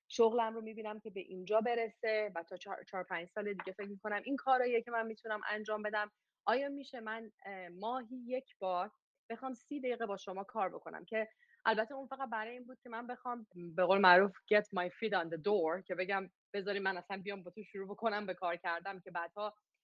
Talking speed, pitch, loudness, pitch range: 210 wpm, 210 Hz, -37 LUFS, 190-230 Hz